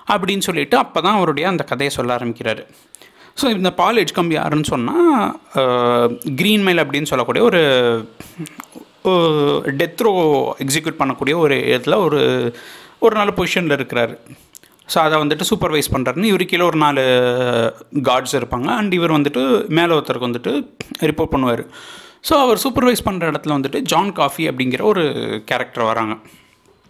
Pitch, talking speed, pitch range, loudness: 155 Hz, 135 wpm, 125-185 Hz, -17 LUFS